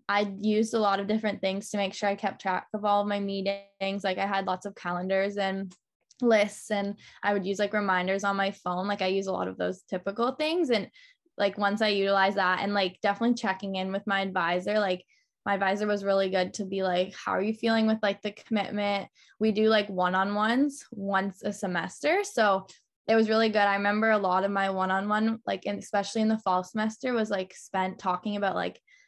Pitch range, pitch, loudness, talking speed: 190-215 Hz, 200 Hz, -28 LUFS, 230 wpm